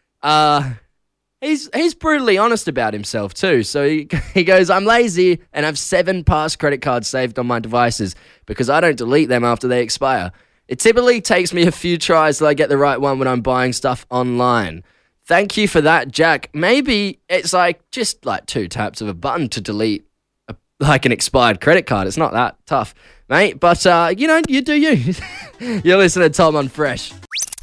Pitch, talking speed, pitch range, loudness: 155 Hz, 200 wpm, 125-185 Hz, -16 LUFS